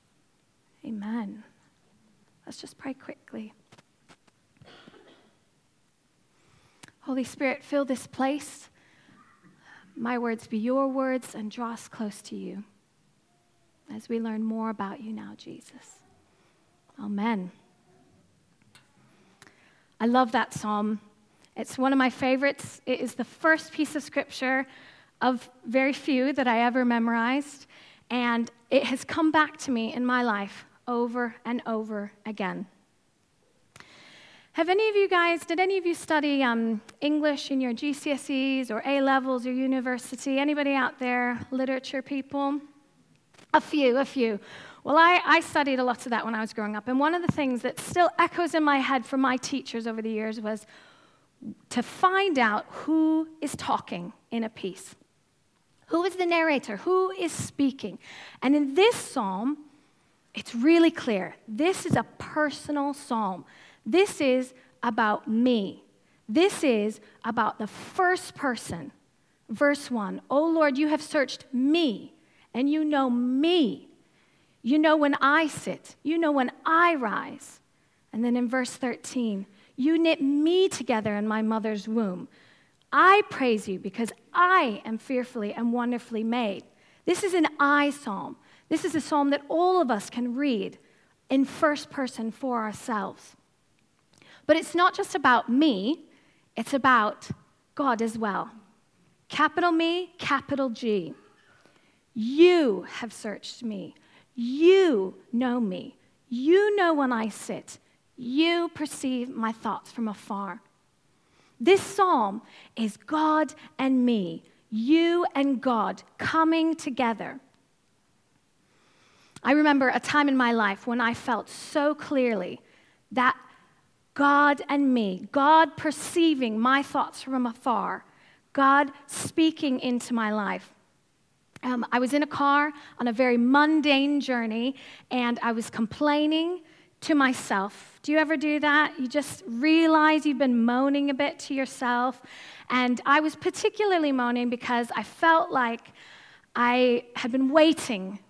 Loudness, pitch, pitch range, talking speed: -26 LUFS, 260 Hz, 230-300 Hz, 140 wpm